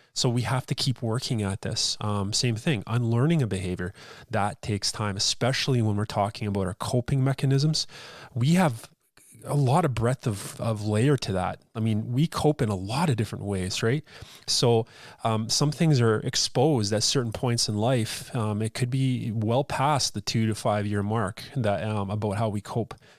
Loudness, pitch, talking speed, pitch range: -26 LUFS, 115 Hz, 195 wpm, 105-135 Hz